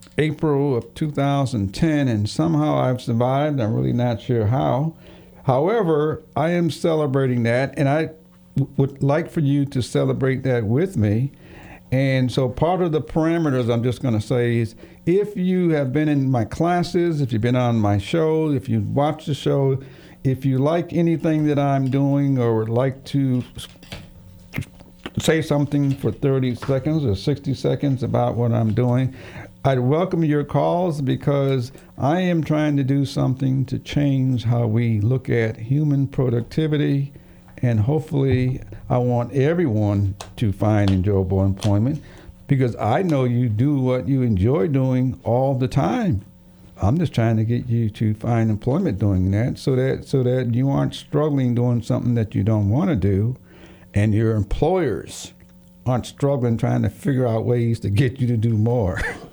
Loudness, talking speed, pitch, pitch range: -21 LUFS, 165 wpm, 130 Hz, 115-145 Hz